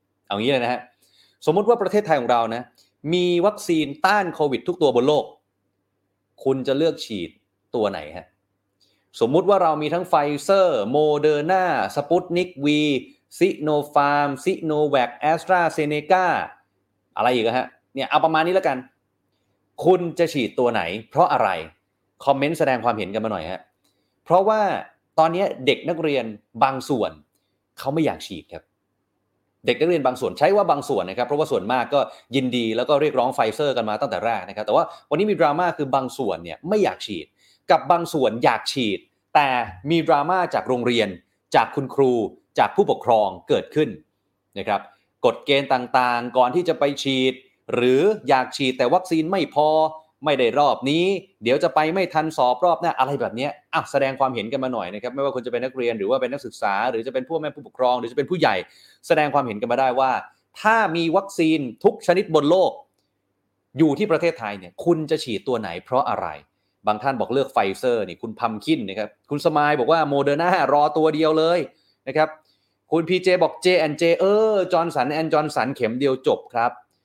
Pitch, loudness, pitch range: 145 Hz, -21 LUFS, 120-165 Hz